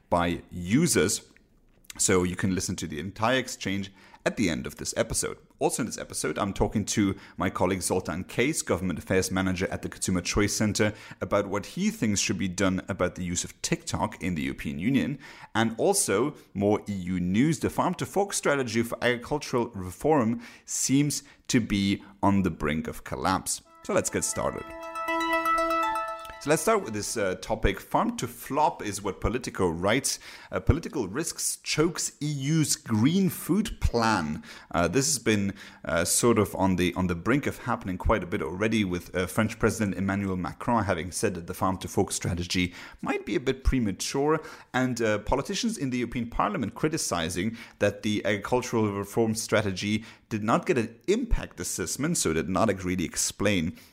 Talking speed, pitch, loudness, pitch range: 175 wpm, 105 Hz, -27 LUFS, 95-125 Hz